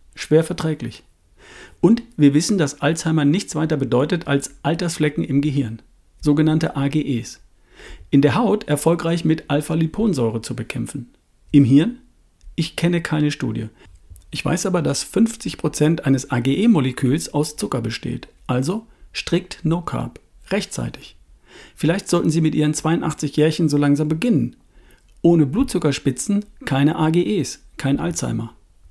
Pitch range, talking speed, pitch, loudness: 135-165 Hz, 120 wpm, 150 Hz, -20 LUFS